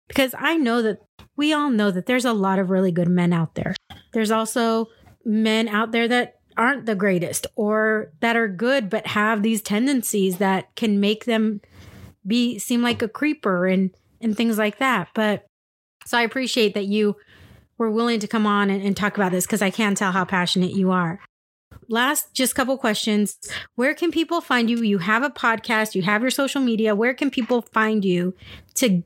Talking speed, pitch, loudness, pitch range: 200 wpm, 220 Hz, -21 LUFS, 200-240 Hz